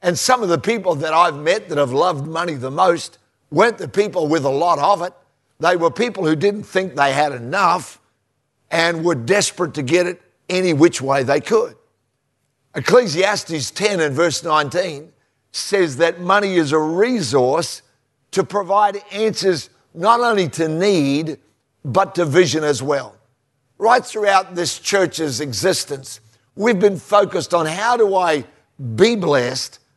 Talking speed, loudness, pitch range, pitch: 160 wpm, -18 LUFS, 145-195 Hz, 170 Hz